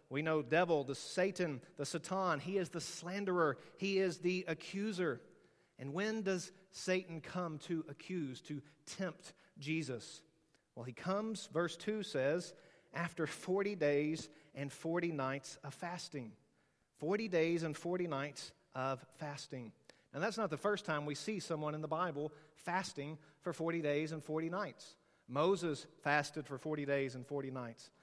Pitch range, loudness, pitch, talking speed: 145-180 Hz, -40 LUFS, 160 Hz, 155 wpm